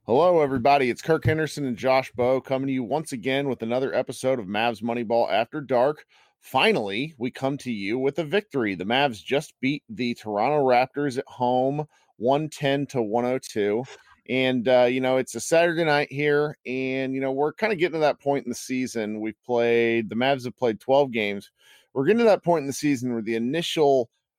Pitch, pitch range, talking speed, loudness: 130 Hz, 120-145 Hz, 200 wpm, -24 LUFS